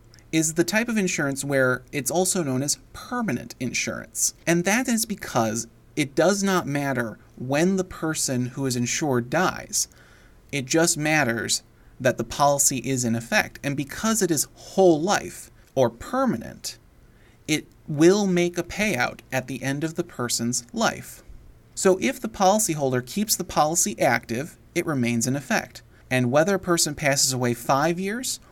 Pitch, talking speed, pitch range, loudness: 145 Hz, 160 wpm, 125-180 Hz, -23 LUFS